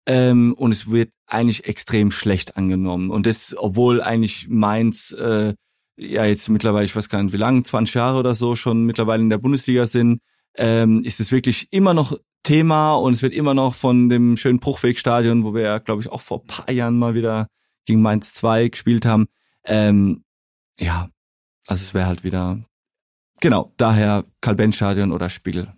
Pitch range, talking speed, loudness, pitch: 105-120 Hz, 180 wpm, -19 LUFS, 115 Hz